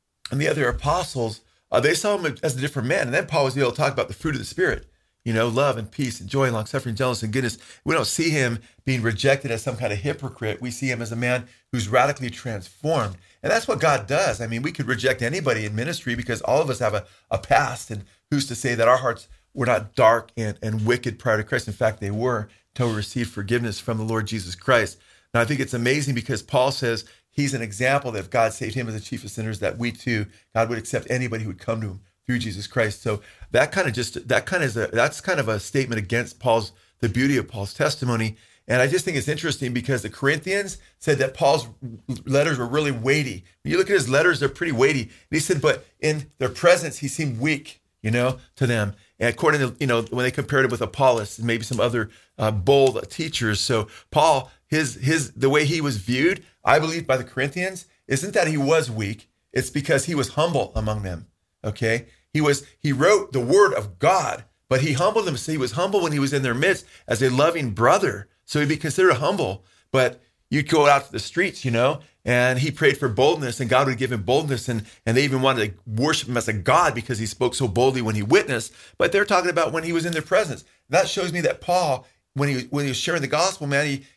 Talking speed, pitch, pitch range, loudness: 245 wpm, 125 Hz, 115-145 Hz, -22 LUFS